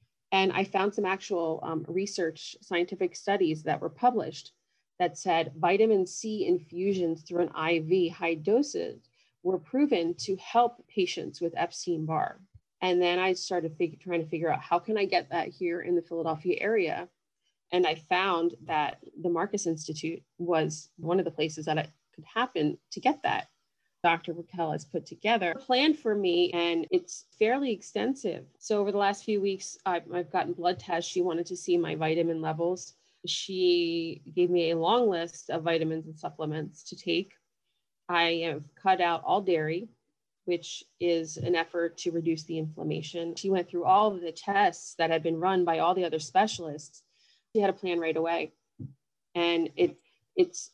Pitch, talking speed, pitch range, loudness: 175 Hz, 175 wpm, 165-195 Hz, -29 LUFS